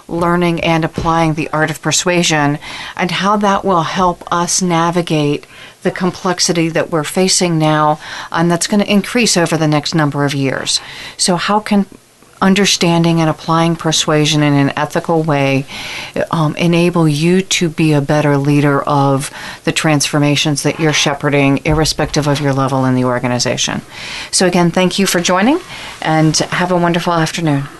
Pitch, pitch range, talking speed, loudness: 165 Hz, 150-175 Hz, 160 wpm, -13 LUFS